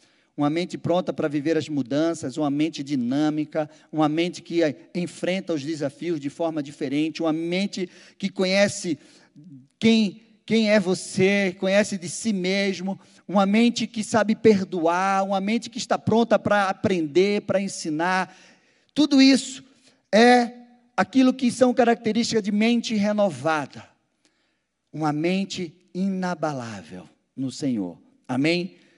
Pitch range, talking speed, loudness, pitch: 160-220 Hz, 125 wpm, -23 LUFS, 185 Hz